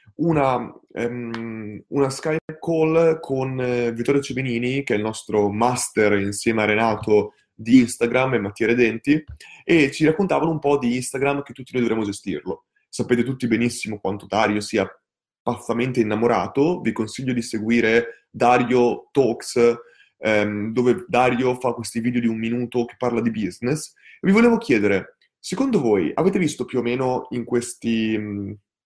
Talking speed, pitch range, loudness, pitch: 155 wpm, 110-130 Hz, -21 LUFS, 120 Hz